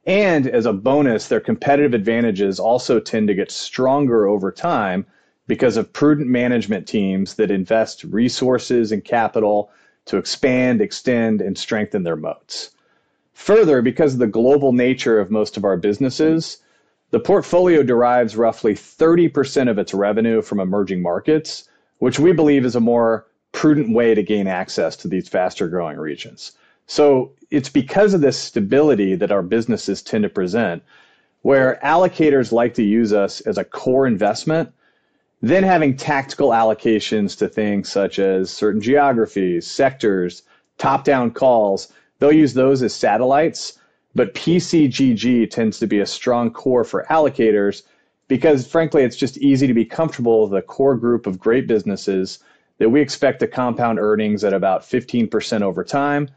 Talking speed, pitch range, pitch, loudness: 155 wpm, 105-140 Hz, 120 Hz, -17 LUFS